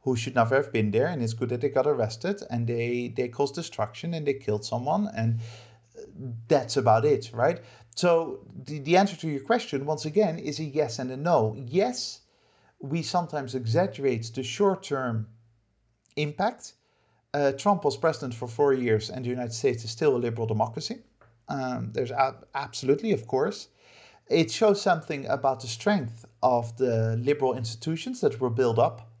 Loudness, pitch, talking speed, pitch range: -27 LUFS, 130 Hz, 175 wpm, 115-155 Hz